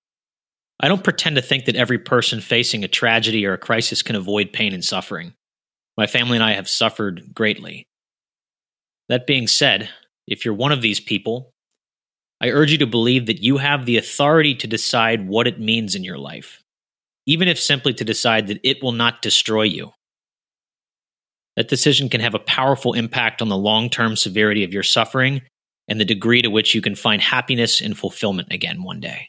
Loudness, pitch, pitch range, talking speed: -18 LUFS, 115 Hz, 110-130 Hz, 190 wpm